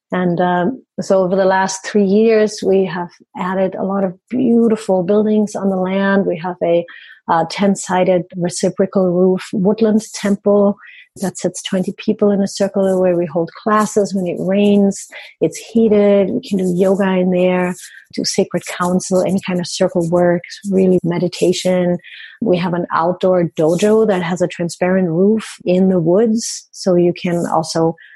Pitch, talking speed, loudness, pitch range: 190 Hz, 165 wpm, -16 LUFS, 180-205 Hz